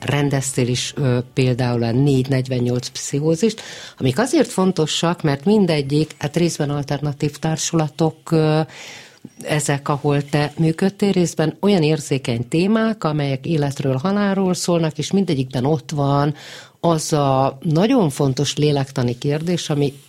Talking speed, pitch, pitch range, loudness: 120 wpm, 150 Hz, 140-165 Hz, -19 LUFS